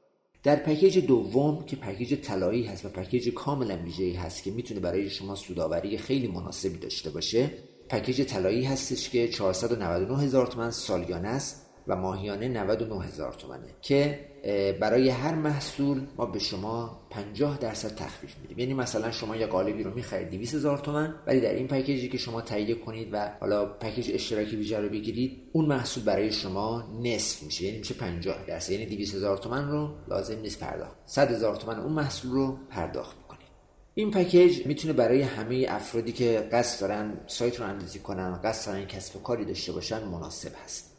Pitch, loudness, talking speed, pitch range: 115 Hz, -29 LUFS, 170 wpm, 100-130 Hz